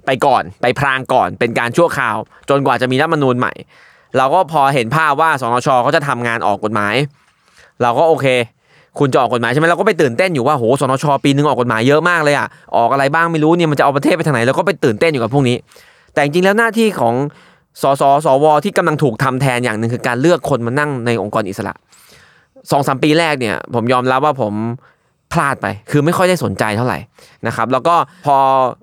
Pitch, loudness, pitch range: 140 Hz, -14 LUFS, 120-155 Hz